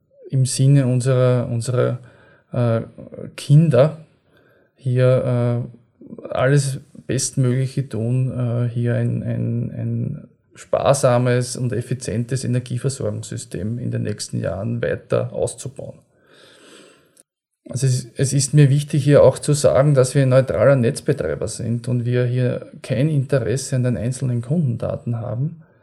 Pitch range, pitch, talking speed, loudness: 120-135 Hz, 125 Hz, 120 wpm, -19 LUFS